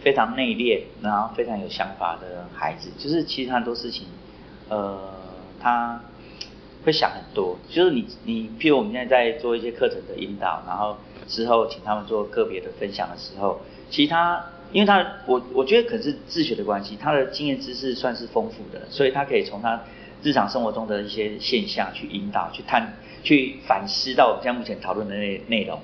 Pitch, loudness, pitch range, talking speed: 120 Hz, -24 LUFS, 105-170 Hz, 300 characters per minute